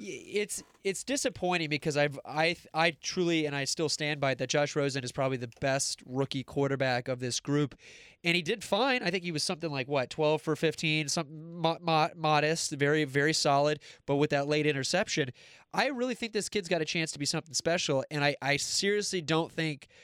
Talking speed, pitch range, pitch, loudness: 205 wpm, 140-170 Hz, 155 Hz, -30 LUFS